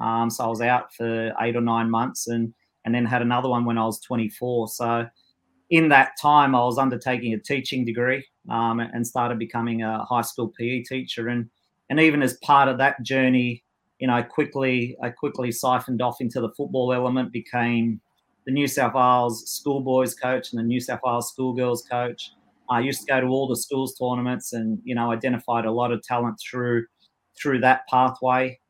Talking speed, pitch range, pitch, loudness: 195 wpm, 115-130 Hz, 120 Hz, -23 LUFS